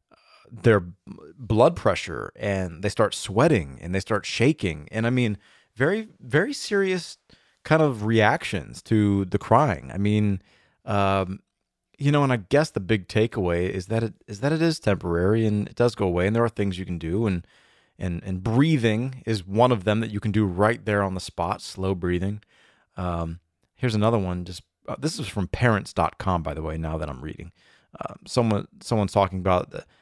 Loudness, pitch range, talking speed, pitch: -24 LUFS, 95-115 Hz, 190 wpm, 105 Hz